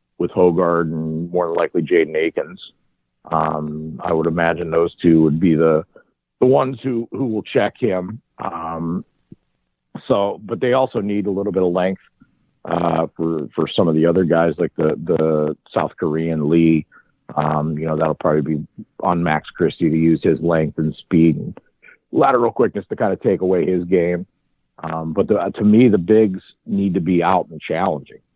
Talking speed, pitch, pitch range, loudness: 185 wpm, 85 Hz, 80-95 Hz, -18 LUFS